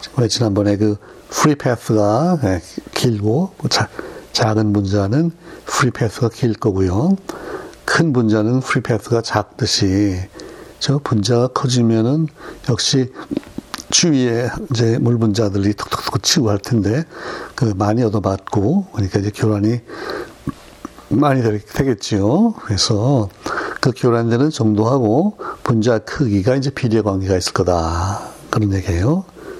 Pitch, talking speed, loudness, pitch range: 115 Hz, 255 characters per minute, -17 LUFS, 105-140 Hz